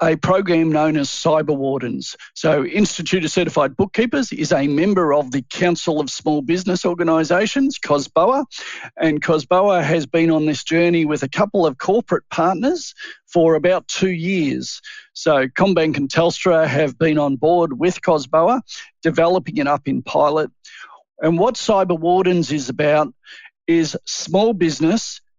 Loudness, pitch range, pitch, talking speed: -18 LUFS, 155-190 Hz, 165 Hz, 150 wpm